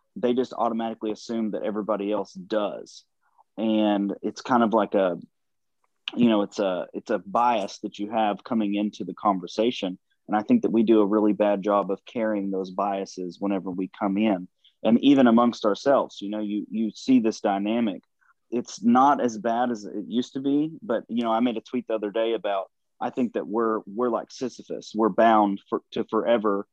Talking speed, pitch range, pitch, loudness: 200 wpm, 100-115 Hz, 110 Hz, -25 LUFS